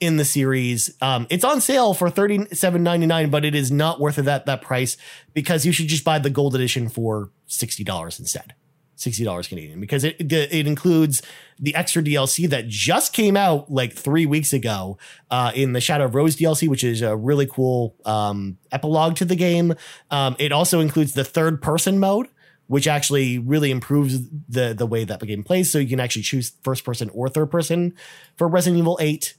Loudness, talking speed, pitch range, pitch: -20 LUFS, 210 wpm, 125-165 Hz, 145 Hz